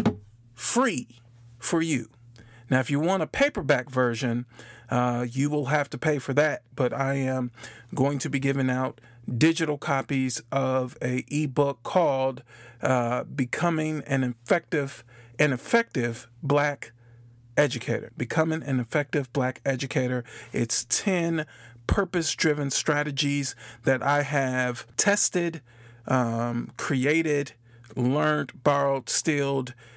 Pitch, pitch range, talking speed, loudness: 135 Hz, 120-150 Hz, 115 wpm, -26 LUFS